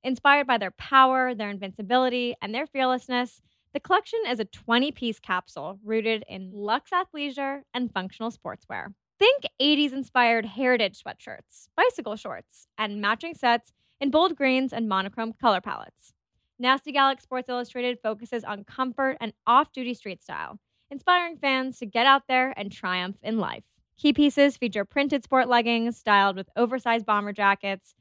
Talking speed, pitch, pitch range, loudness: 155 wpm, 245 Hz, 220-270 Hz, -25 LUFS